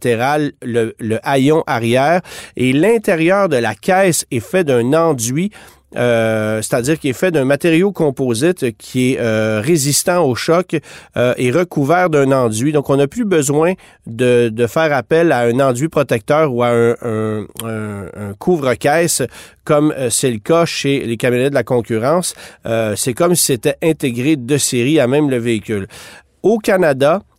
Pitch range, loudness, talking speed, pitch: 120-160 Hz, -15 LUFS, 165 wpm, 135 Hz